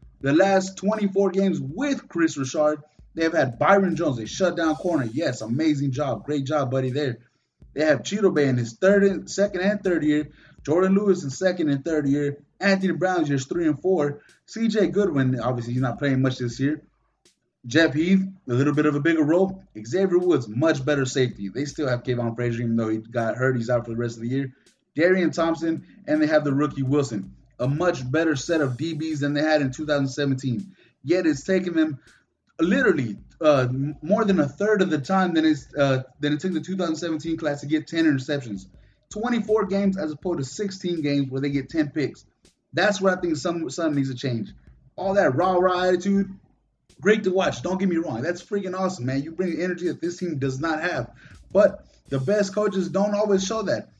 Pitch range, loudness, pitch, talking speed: 135-185 Hz, -23 LUFS, 155 Hz, 210 wpm